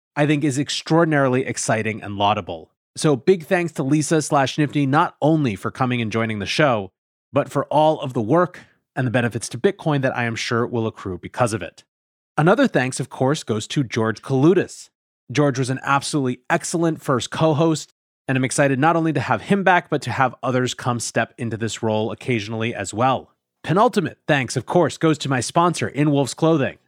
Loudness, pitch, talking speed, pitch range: -20 LUFS, 135 Hz, 200 wpm, 120-155 Hz